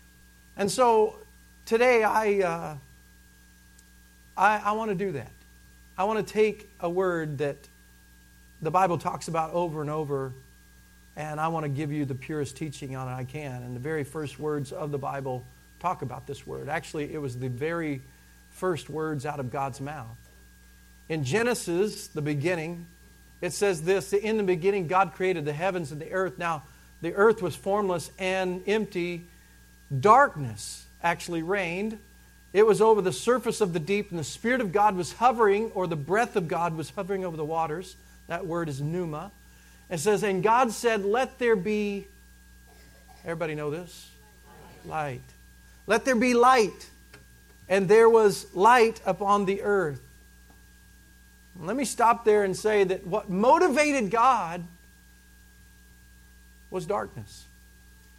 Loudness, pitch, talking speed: -26 LUFS, 160 Hz, 160 wpm